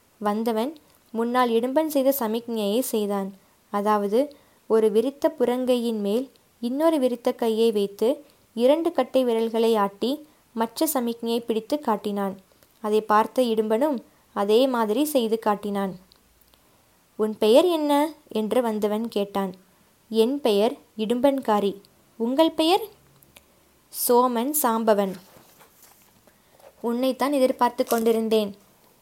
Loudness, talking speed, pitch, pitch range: -23 LUFS, 95 wpm, 230 Hz, 215-260 Hz